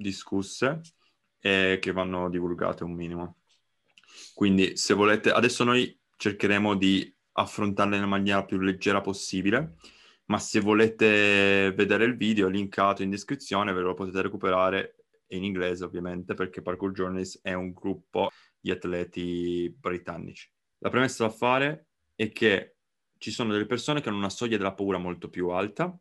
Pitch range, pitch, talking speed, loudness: 90-105 Hz, 95 Hz, 150 wpm, -27 LUFS